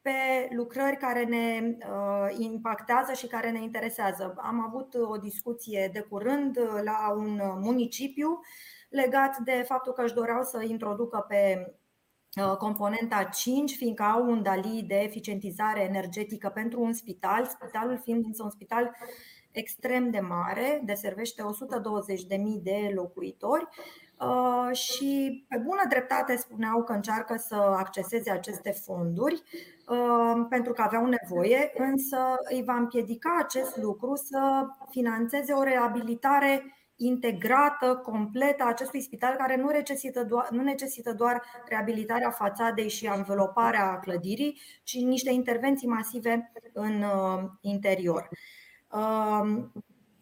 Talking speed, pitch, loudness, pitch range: 125 wpm, 235 Hz, -29 LUFS, 210-255 Hz